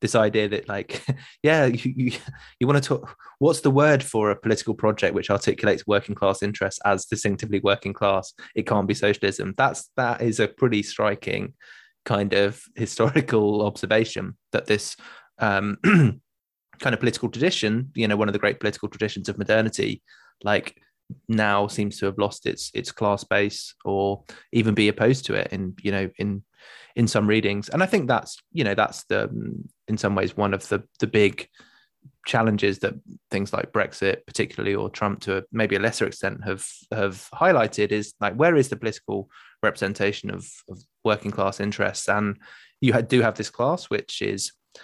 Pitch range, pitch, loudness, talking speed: 100-120 Hz, 105 Hz, -24 LUFS, 180 wpm